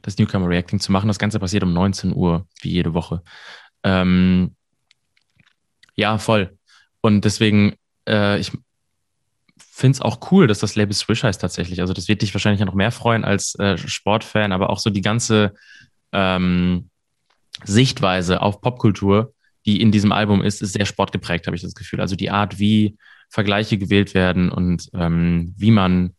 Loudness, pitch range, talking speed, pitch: -19 LUFS, 95-105 Hz, 170 wpm, 100 Hz